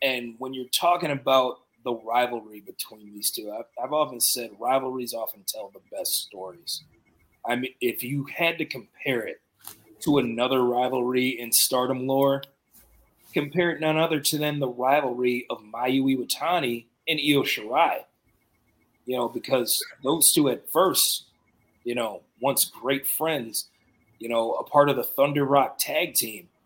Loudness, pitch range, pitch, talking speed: -25 LUFS, 120-140 Hz, 130 Hz, 160 wpm